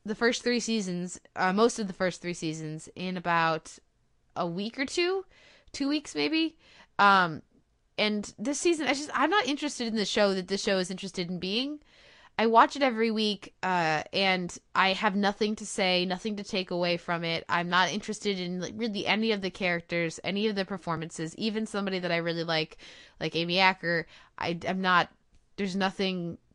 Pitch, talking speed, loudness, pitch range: 190 Hz, 190 wpm, -28 LUFS, 175-220 Hz